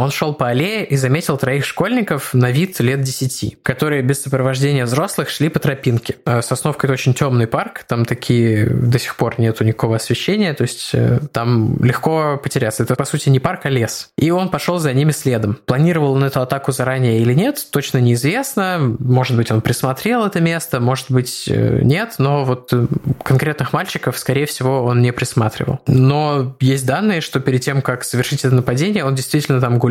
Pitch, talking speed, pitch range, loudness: 135 Hz, 185 wpm, 125-150 Hz, -17 LUFS